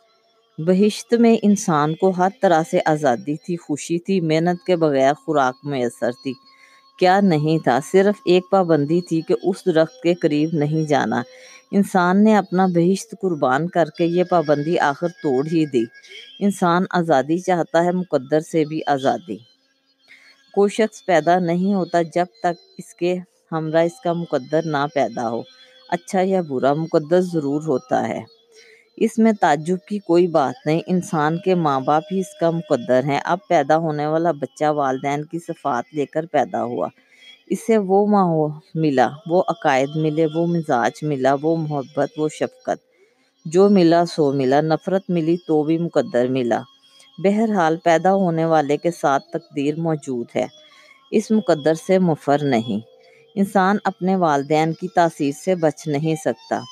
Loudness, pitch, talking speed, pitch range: -19 LUFS, 170 Hz, 160 wpm, 150-190 Hz